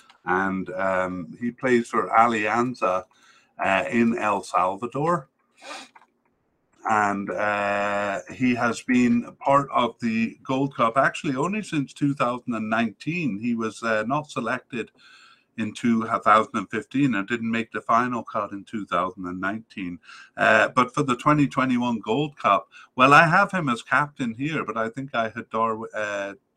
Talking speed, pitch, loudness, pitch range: 135 wpm, 120 Hz, -23 LUFS, 105-140 Hz